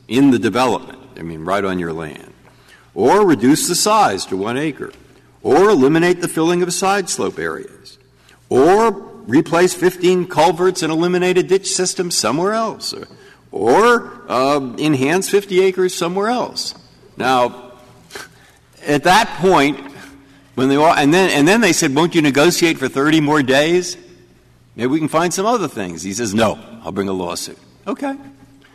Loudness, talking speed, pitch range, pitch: -15 LUFS, 165 wpm, 130-185 Hz, 160 Hz